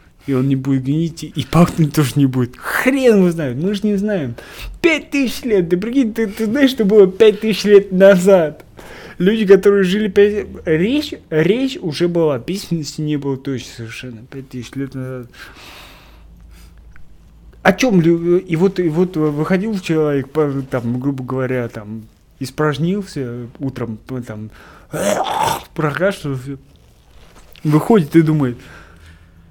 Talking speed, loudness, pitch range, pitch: 140 wpm, -16 LUFS, 125-195 Hz, 155 Hz